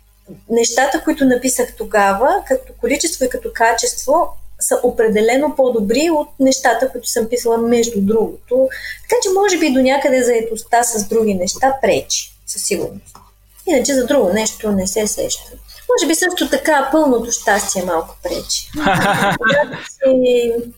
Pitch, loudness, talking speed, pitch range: 250 Hz, -16 LUFS, 135 wpm, 230-295 Hz